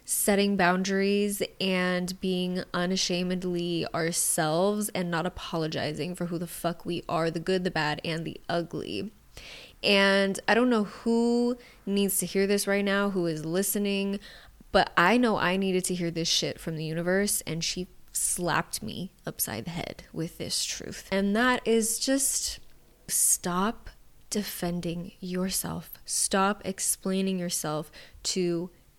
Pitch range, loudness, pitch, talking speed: 170-200 Hz, -27 LUFS, 185 Hz, 145 wpm